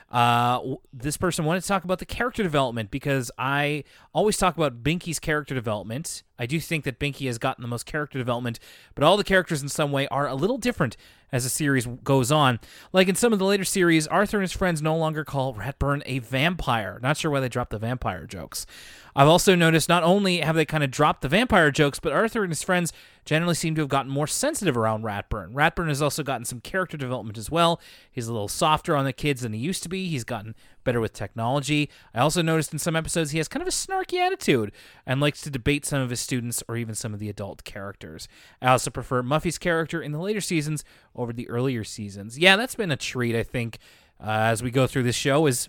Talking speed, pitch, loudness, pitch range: 235 wpm, 145 Hz, -24 LUFS, 120-165 Hz